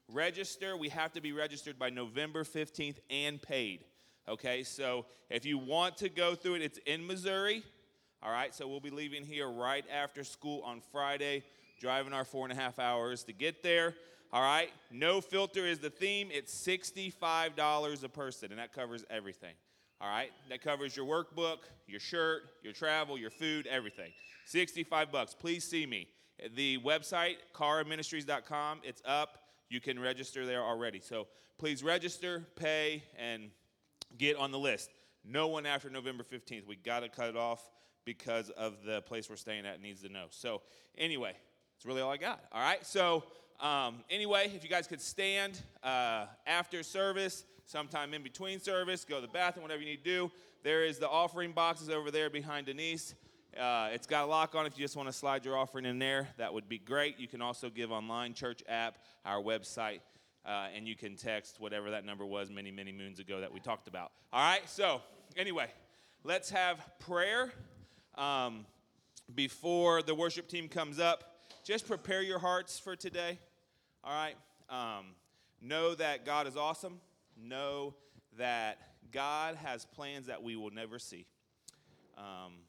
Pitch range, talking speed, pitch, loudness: 120-165 Hz, 180 wpm, 145 Hz, -37 LUFS